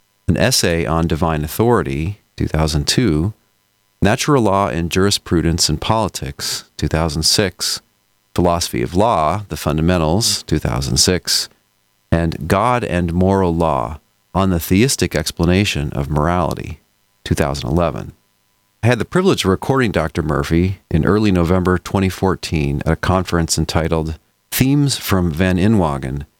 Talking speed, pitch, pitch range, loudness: 115 wpm, 90 Hz, 80-100 Hz, -17 LUFS